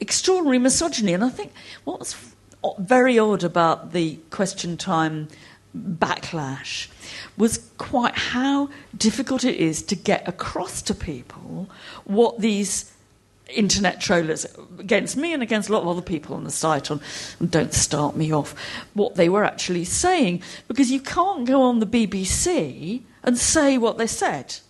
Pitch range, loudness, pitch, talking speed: 165-250 Hz, -22 LUFS, 200 Hz, 155 wpm